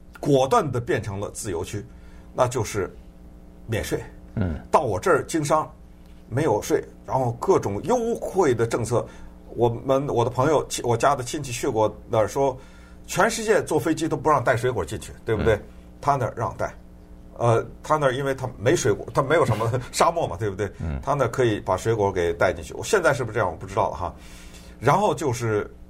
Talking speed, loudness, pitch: 285 characters per minute, -24 LUFS, 100 Hz